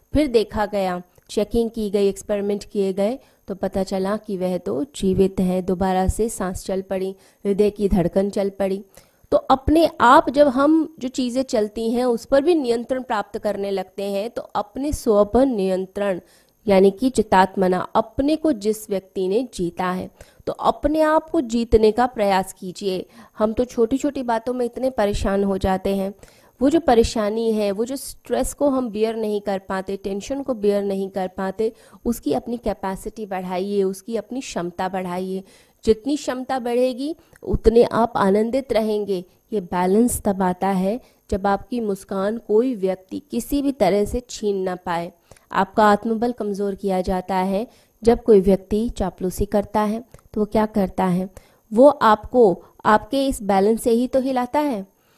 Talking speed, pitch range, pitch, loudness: 170 wpm, 195-240 Hz, 210 Hz, -21 LUFS